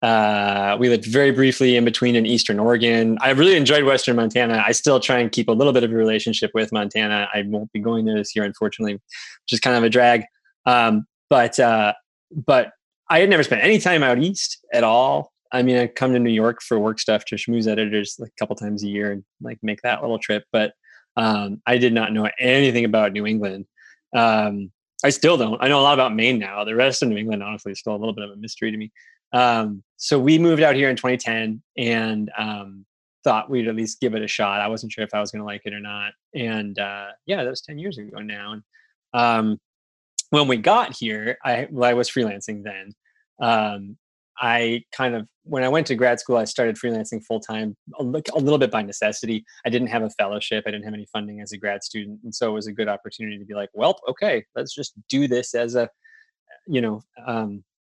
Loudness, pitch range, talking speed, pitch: -20 LUFS, 105-125 Hz, 230 wpm, 115 Hz